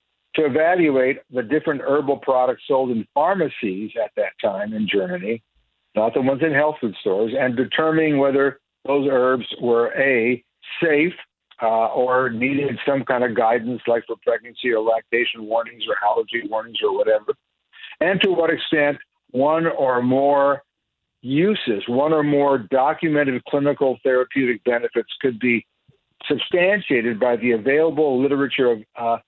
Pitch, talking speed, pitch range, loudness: 135 Hz, 145 wpm, 120-150 Hz, -20 LUFS